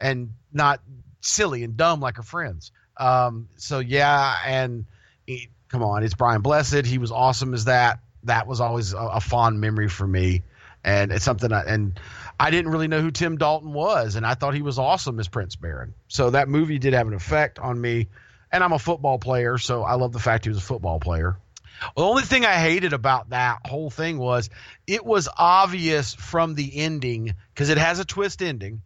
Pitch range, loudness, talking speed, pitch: 110-145 Hz, -22 LUFS, 210 wpm, 125 Hz